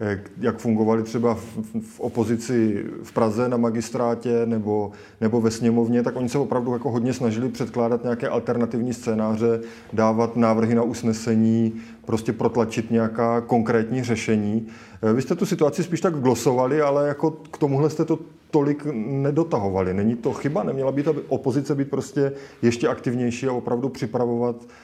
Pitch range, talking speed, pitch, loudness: 115-135 Hz, 150 wpm, 120 Hz, -23 LUFS